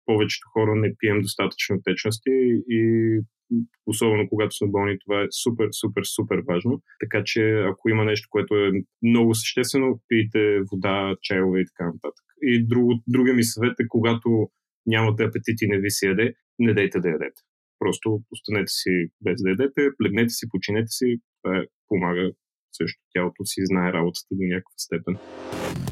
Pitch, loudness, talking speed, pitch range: 110 Hz, -23 LUFS, 160 wpm, 100-115 Hz